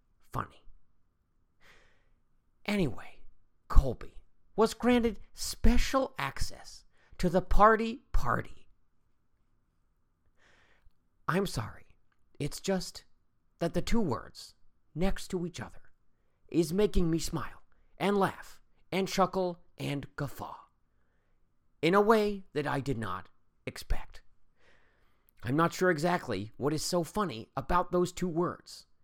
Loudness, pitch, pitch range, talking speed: -31 LUFS, 175 Hz, 125-190 Hz, 110 wpm